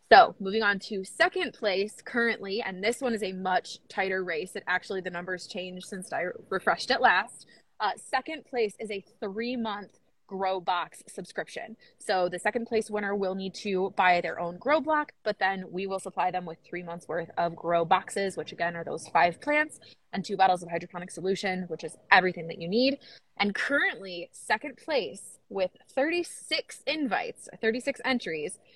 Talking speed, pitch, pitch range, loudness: 185 wpm, 195 Hz, 185-235 Hz, -29 LUFS